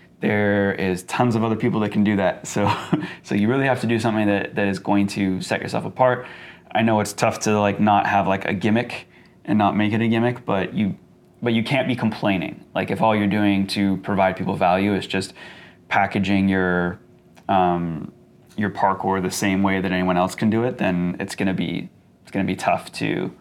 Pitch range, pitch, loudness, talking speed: 95-110 Hz, 100 Hz, -21 LUFS, 215 wpm